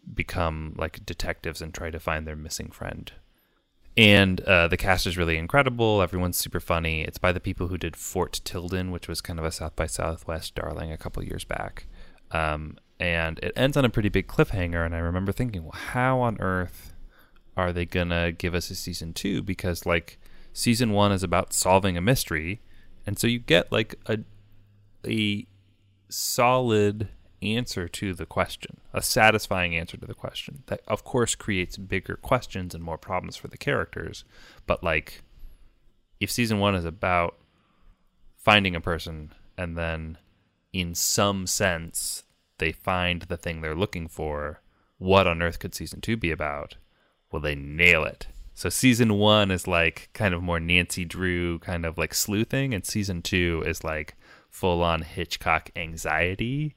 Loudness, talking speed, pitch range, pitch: -25 LUFS, 170 wpm, 85-100 Hz, 90 Hz